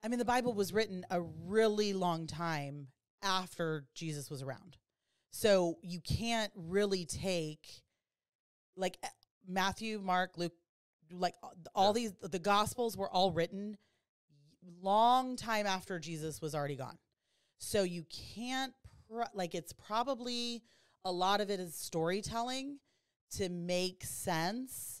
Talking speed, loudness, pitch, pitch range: 130 wpm, -36 LUFS, 185 Hz, 170-215 Hz